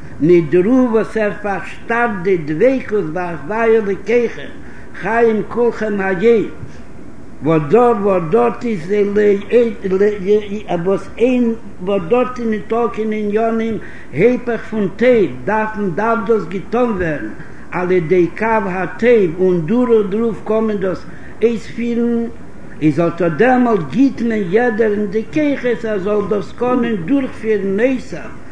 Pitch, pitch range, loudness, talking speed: 215 Hz, 195-235 Hz, -16 LUFS, 135 wpm